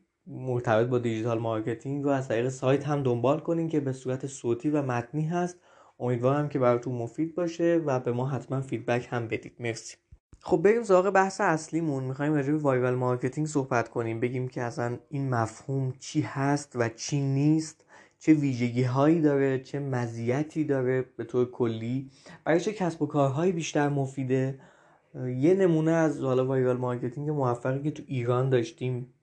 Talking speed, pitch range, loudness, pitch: 165 wpm, 125-150 Hz, -28 LUFS, 135 Hz